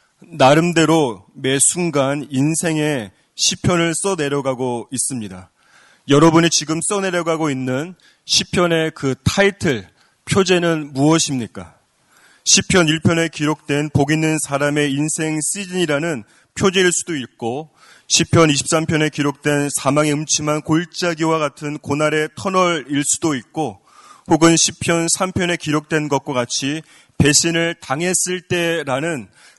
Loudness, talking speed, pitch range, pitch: -17 LUFS, 260 characters per minute, 145-170 Hz, 155 Hz